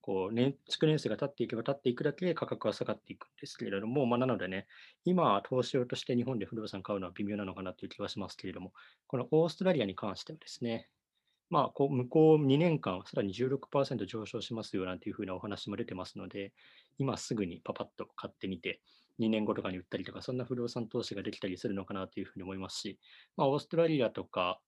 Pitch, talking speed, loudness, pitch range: 115 Hz, 470 characters per minute, -34 LUFS, 100-135 Hz